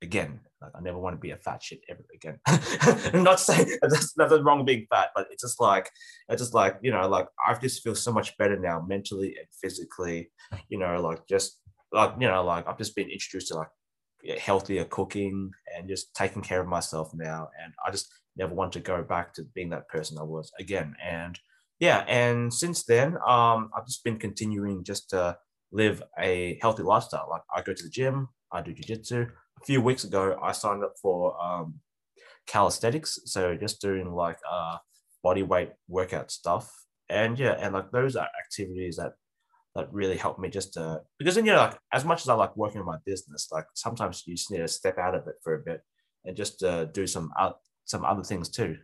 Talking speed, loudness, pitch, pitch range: 215 wpm, -28 LUFS, 100 Hz, 90-120 Hz